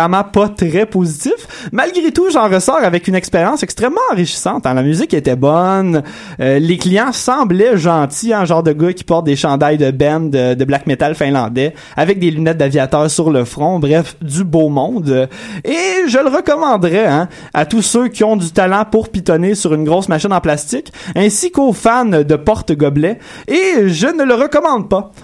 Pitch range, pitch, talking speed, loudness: 150-215 Hz, 175 Hz, 190 wpm, -13 LUFS